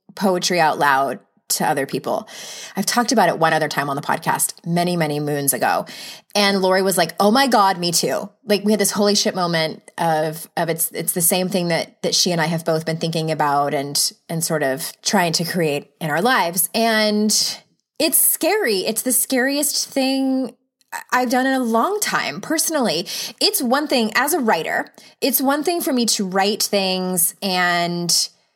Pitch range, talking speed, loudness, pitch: 165-245 Hz, 195 wpm, -18 LUFS, 195 Hz